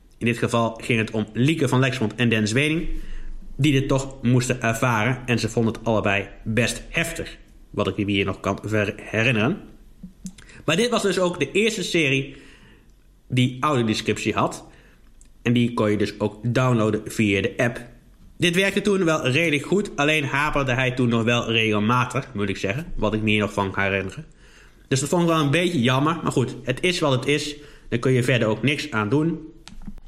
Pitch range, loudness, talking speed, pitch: 110-150 Hz, -22 LUFS, 200 wpm, 125 Hz